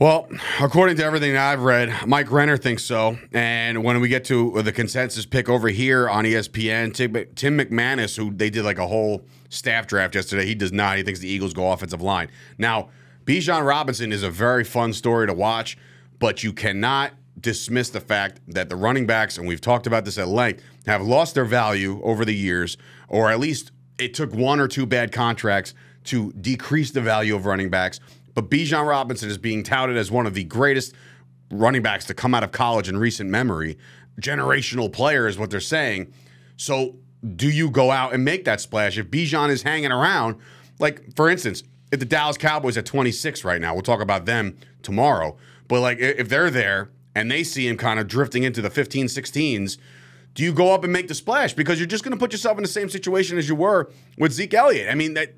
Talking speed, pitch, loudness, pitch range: 215 wpm, 120 Hz, -21 LUFS, 100-135 Hz